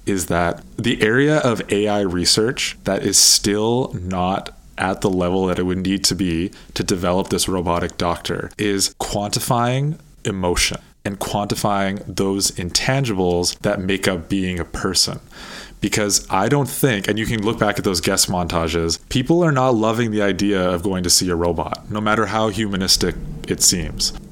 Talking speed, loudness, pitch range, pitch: 170 wpm, -19 LUFS, 90-110 Hz, 100 Hz